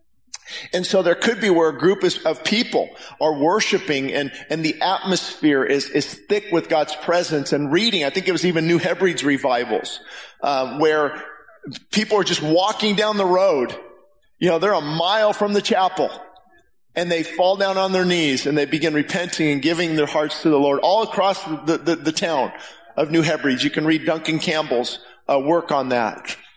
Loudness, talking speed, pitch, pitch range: -20 LUFS, 190 wpm, 165 Hz, 150-185 Hz